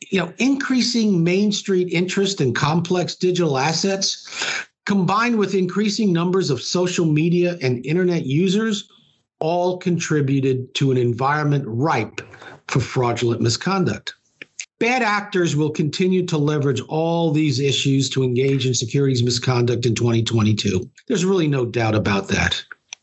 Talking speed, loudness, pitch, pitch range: 135 wpm, -20 LUFS, 160 Hz, 130-185 Hz